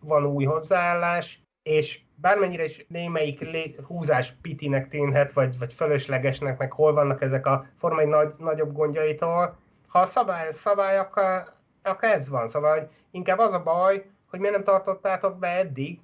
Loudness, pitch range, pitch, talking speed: -25 LUFS, 145-185 Hz, 155 Hz, 155 wpm